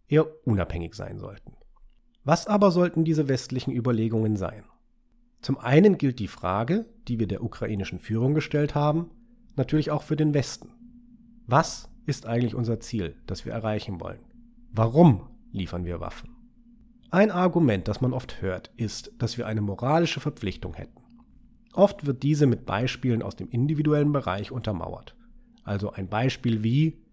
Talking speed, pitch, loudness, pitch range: 150 wpm, 130 Hz, -26 LUFS, 110-170 Hz